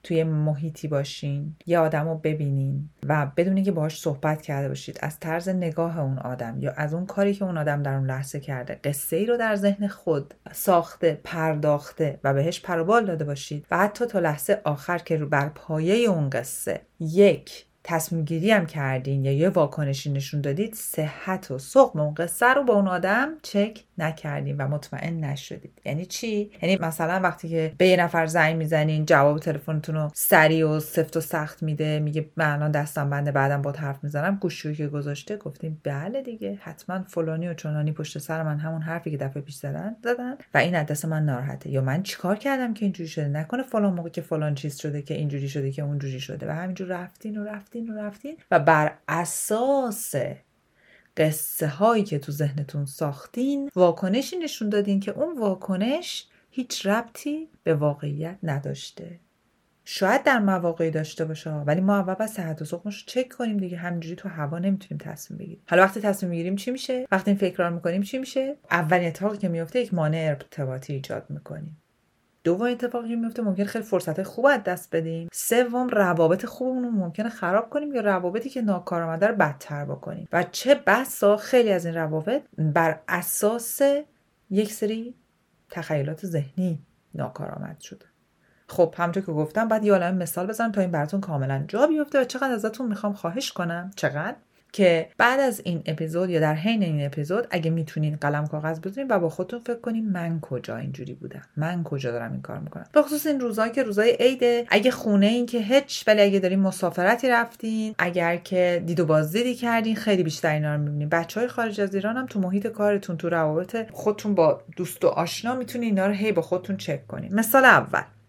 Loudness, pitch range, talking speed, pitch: -25 LUFS, 155-210 Hz, 185 wpm, 175 Hz